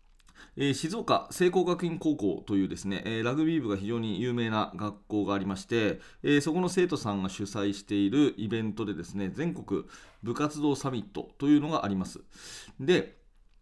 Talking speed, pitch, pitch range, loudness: 330 characters per minute, 115 Hz, 100-150 Hz, -30 LUFS